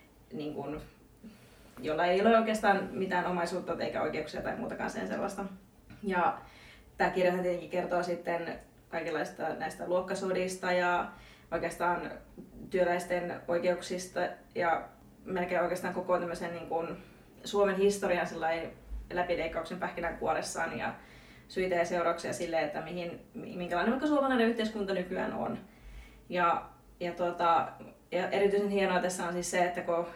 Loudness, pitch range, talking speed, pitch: -32 LUFS, 170-185 Hz, 125 wpm, 180 Hz